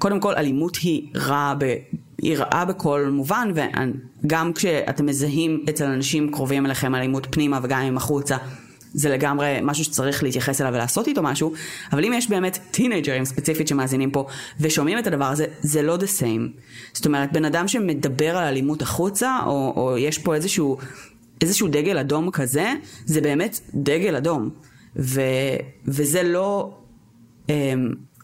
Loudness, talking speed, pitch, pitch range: -22 LUFS, 155 wpm, 145 Hz, 135-160 Hz